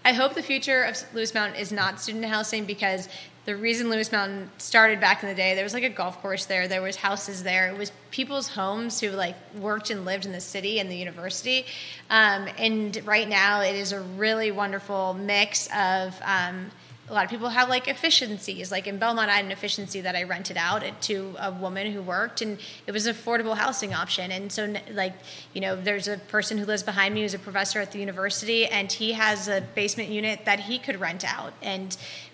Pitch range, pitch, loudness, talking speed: 190-220 Hz, 205 Hz, -25 LUFS, 225 wpm